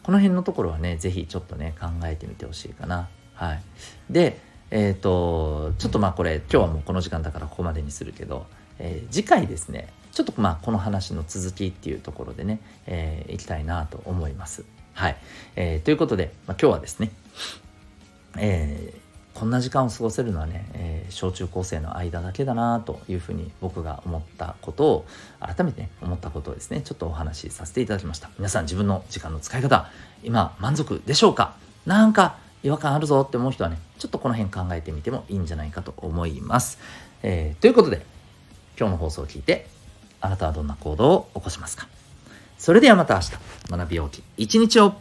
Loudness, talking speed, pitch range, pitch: -24 LUFS, 385 characters per minute, 80-105 Hz, 90 Hz